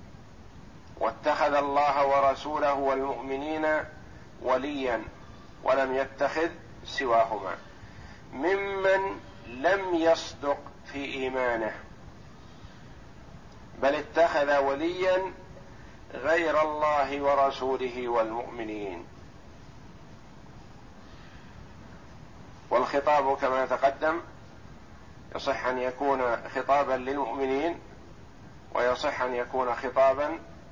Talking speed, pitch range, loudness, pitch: 65 wpm, 130-150 Hz, -28 LUFS, 140 Hz